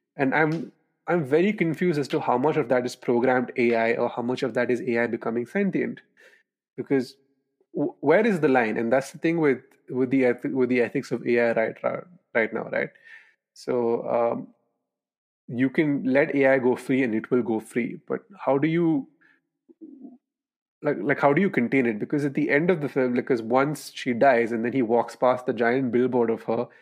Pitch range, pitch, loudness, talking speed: 120-155 Hz, 135 Hz, -24 LUFS, 200 wpm